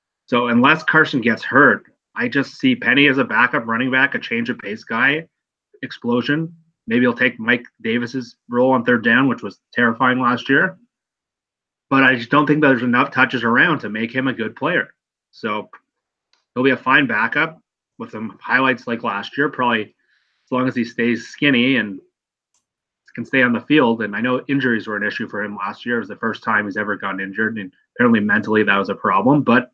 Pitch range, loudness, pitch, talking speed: 115-145 Hz, -18 LUFS, 125 Hz, 210 wpm